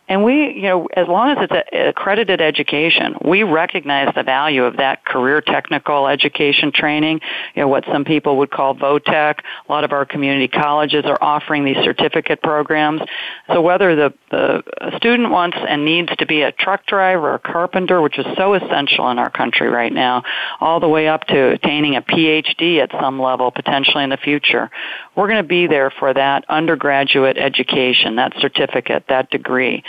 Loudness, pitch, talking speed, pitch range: -15 LUFS, 150 Hz, 185 wpm, 140-175 Hz